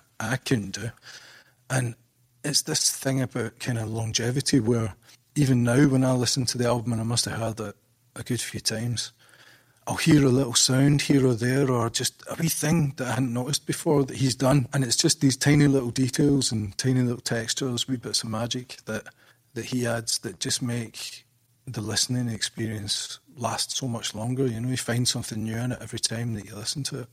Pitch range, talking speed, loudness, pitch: 115-135 Hz, 210 wpm, -25 LUFS, 125 Hz